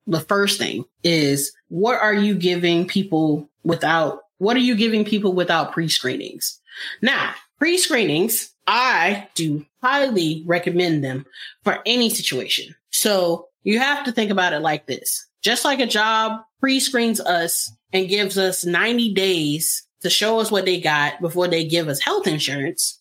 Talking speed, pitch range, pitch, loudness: 160 wpm, 165-215 Hz, 185 Hz, -20 LUFS